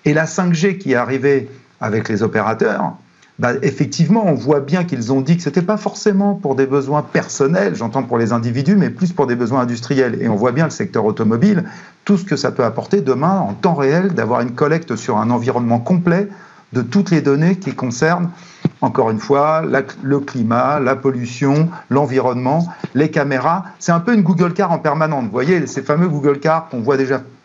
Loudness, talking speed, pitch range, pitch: -16 LUFS, 205 wpm, 130-175 Hz, 145 Hz